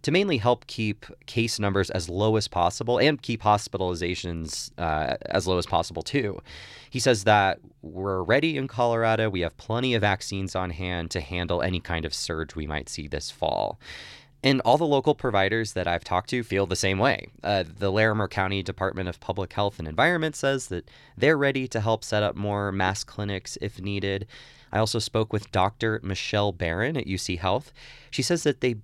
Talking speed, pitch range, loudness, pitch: 195 wpm, 95-120 Hz, -26 LUFS, 100 Hz